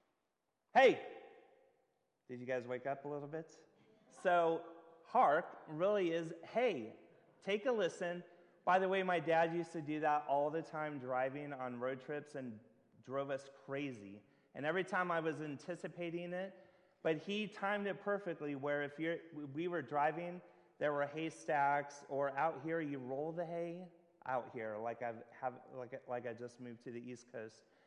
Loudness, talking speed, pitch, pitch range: -39 LUFS, 170 wpm, 155 Hz, 135-175 Hz